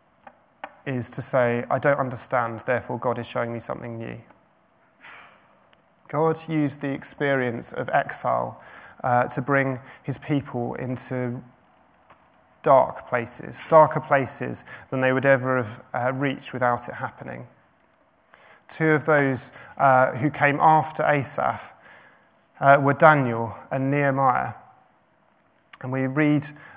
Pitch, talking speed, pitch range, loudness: 135 Hz, 125 wpm, 125-145 Hz, -23 LUFS